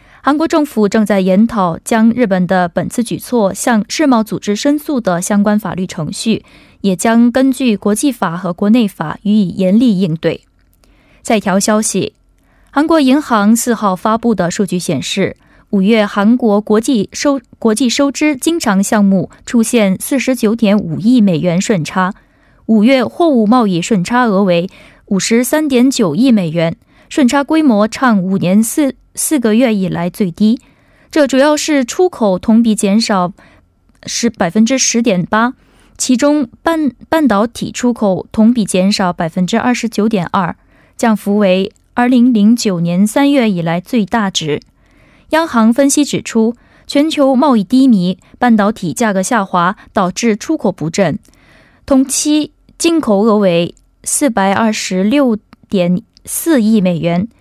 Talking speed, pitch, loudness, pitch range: 230 characters per minute, 220 Hz, -13 LUFS, 195-255 Hz